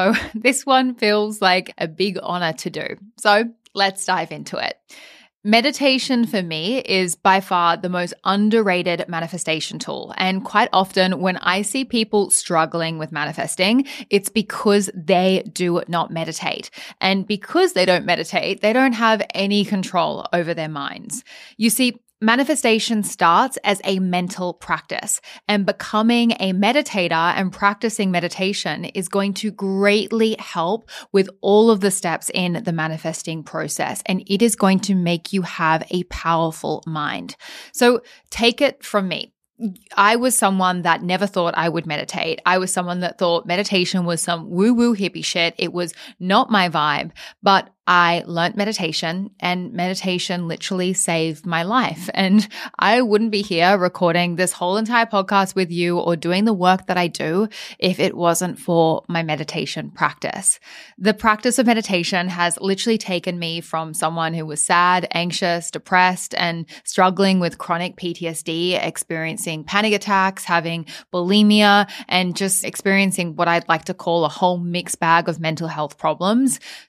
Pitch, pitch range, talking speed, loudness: 185 Hz, 170-210 Hz, 160 wpm, -19 LUFS